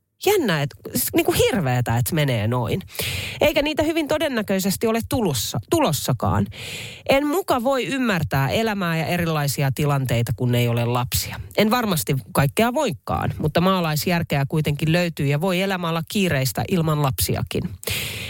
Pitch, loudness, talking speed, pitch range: 155 Hz, -21 LUFS, 130 wpm, 125-210 Hz